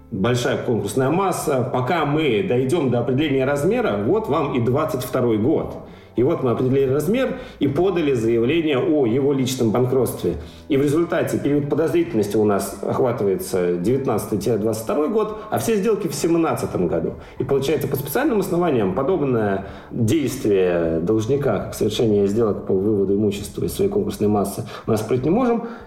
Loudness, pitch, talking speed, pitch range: -20 LUFS, 130 Hz, 150 wpm, 105-170 Hz